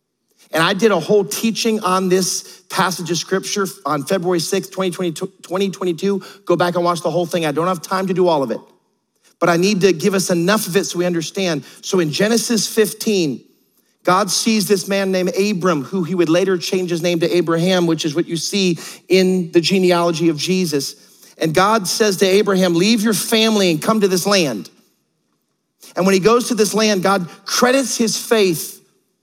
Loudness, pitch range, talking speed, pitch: -17 LUFS, 175-200 Hz, 200 wpm, 185 Hz